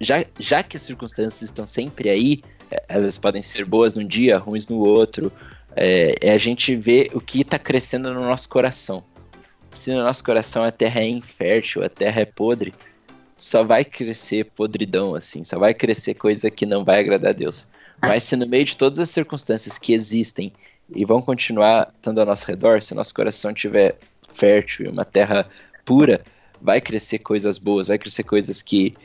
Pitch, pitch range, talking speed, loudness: 110 Hz, 105-125 Hz, 185 wpm, -19 LUFS